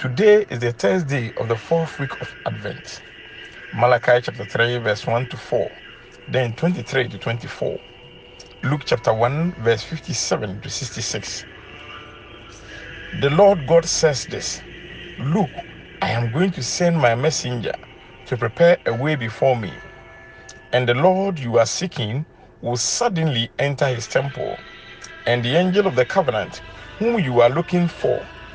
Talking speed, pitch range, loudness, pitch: 145 wpm, 120-170 Hz, -20 LUFS, 135 Hz